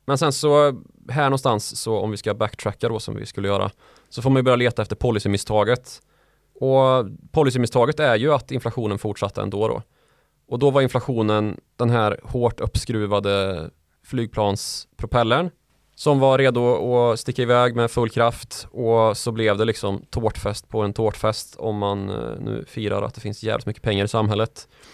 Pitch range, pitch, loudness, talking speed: 105-125 Hz, 115 Hz, -22 LUFS, 170 wpm